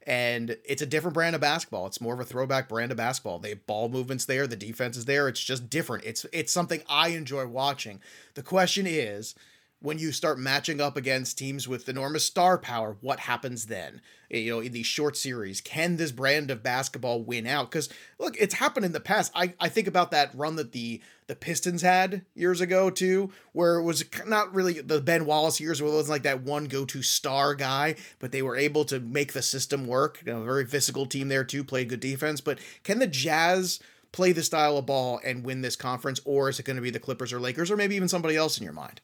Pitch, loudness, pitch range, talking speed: 140 Hz, -27 LUFS, 130-160 Hz, 235 wpm